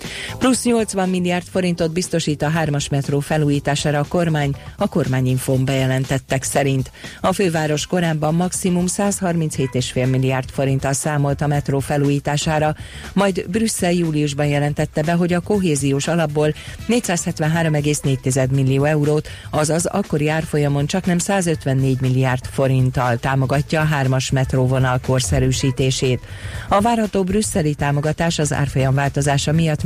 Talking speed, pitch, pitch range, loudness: 120 wpm, 150 Hz, 135-170 Hz, -19 LUFS